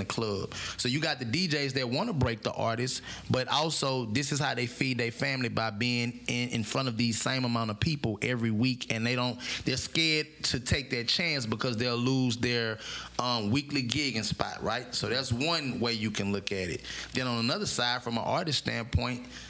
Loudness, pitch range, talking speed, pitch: -30 LUFS, 115-135 Hz, 220 wpm, 120 Hz